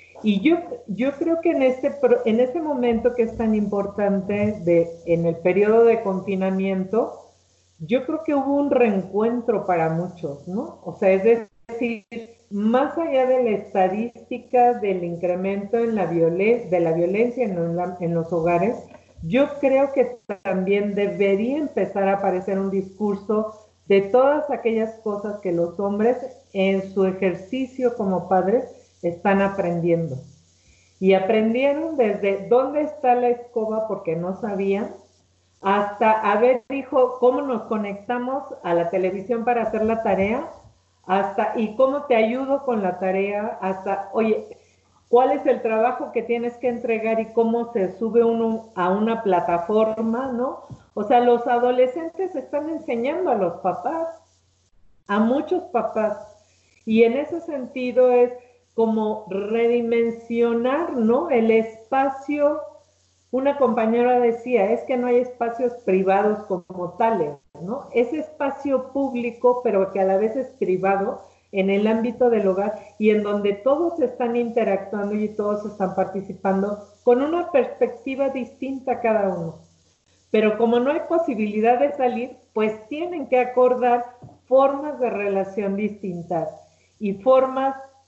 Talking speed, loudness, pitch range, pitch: 140 wpm, -22 LUFS, 195-250 Hz, 225 Hz